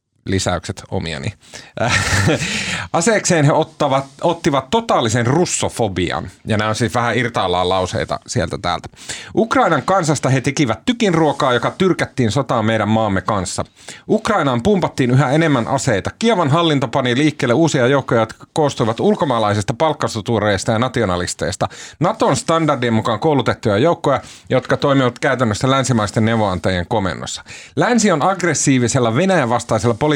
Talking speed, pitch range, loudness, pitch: 125 wpm, 110-155 Hz, -17 LUFS, 130 Hz